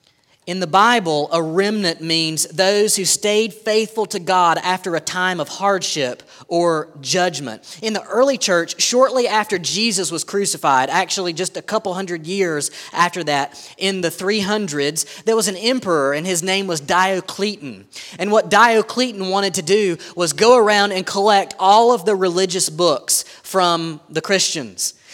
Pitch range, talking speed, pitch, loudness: 170-205 Hz, 160 wpm, 190 Hz, -17 LUFS